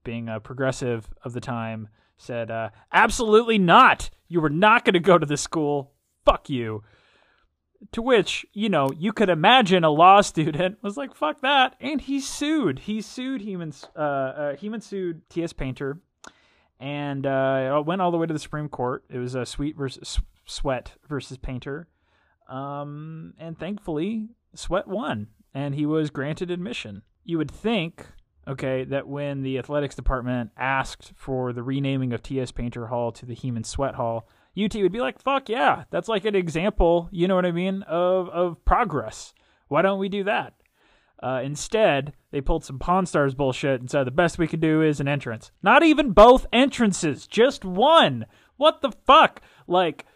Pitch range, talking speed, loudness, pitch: 130-195 Hz, 175 wpm, -23 LUFS, 155 Hz